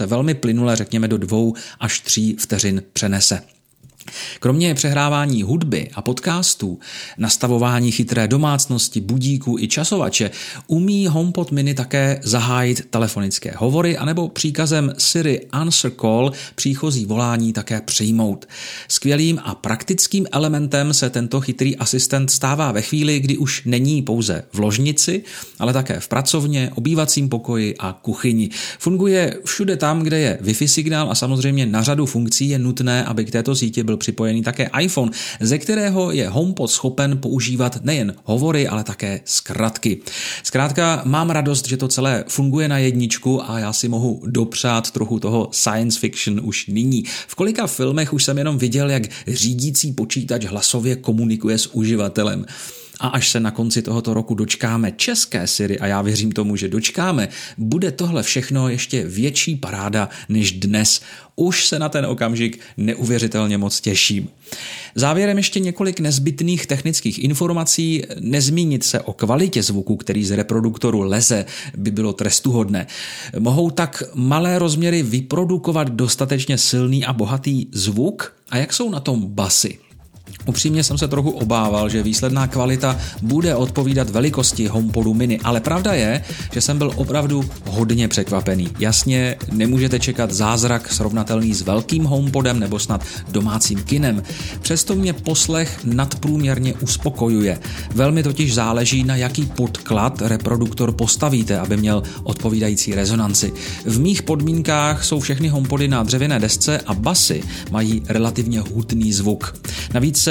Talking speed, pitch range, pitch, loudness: 145 wpm, 110-145 Hz, 125 Hz, -18 LUFS